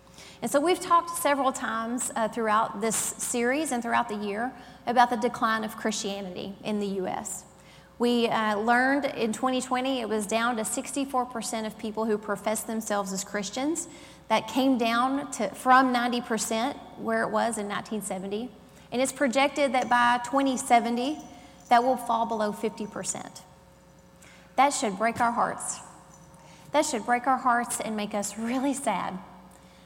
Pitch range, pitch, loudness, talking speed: 220-255 Hz, 235 Hz, -27 LUFS, 155 wpm